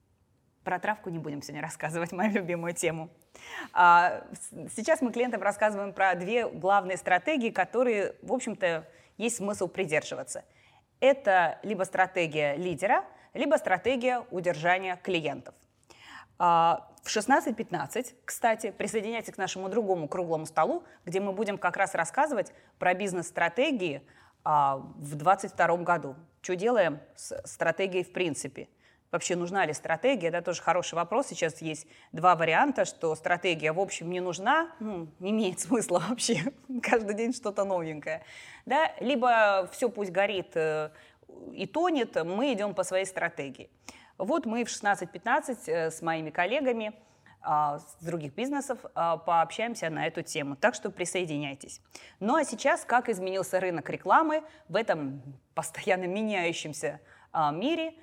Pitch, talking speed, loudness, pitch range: 185 Hz, 130 wpm, -29 LUFS, 165-230 Hz